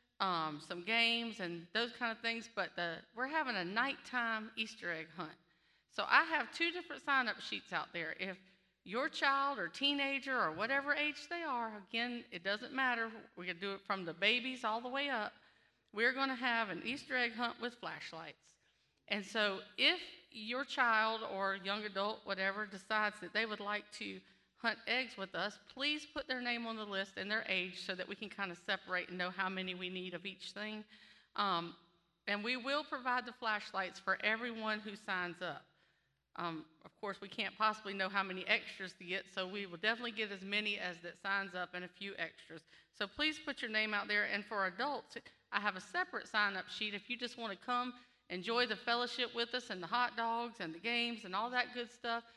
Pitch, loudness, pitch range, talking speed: 215 Hz, -38 LUFS, 190-245 Hz, 210 wpm